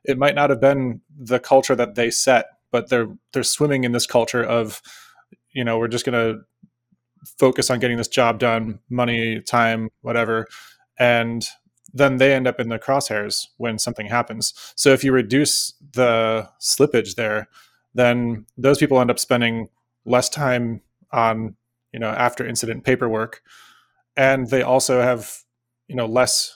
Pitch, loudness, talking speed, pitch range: 120 Hz, -20 LUFS, 165 wpm, 115-130 Hz